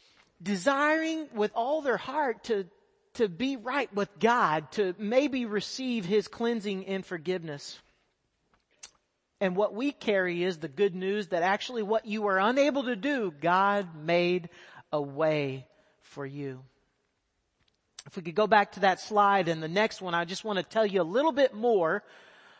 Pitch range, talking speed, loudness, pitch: 175-235 Hz, 165 wpm, -28 LUFS, 200 Hz